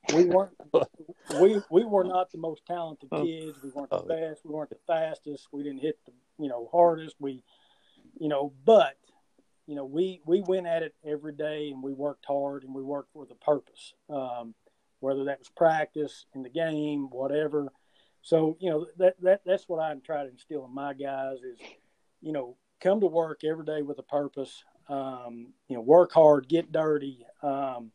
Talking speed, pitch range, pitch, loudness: 195 wpm, 140-165 Hz, 150 Hz, -28 LUFS